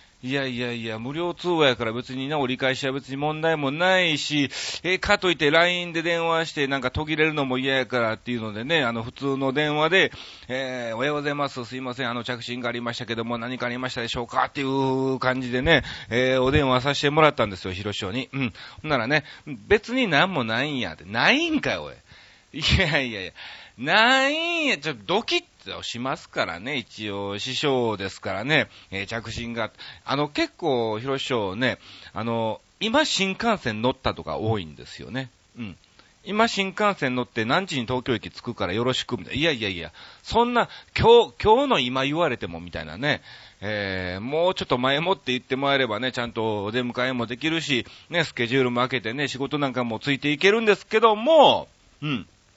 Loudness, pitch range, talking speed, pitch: -23 LUFS, 120-160 Hz, 390 characters per minute, 130 Hz